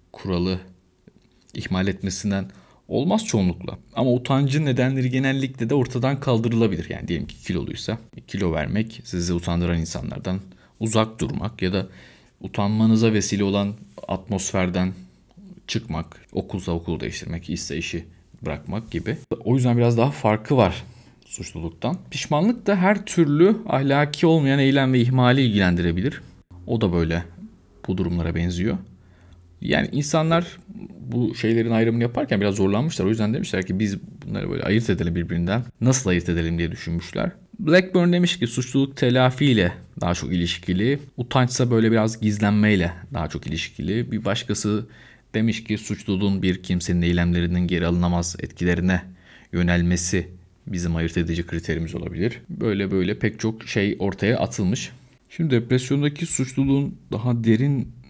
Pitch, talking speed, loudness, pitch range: 105 Hz, 130 wpm, -22 LUFS, 90-125 Hz